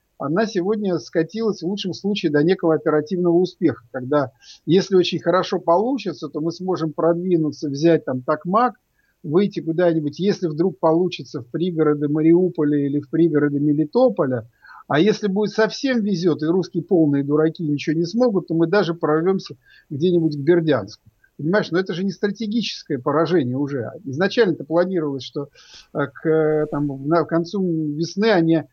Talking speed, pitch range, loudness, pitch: 150 wpm, 150-185 Hz, -20 LUFS, 165 Hz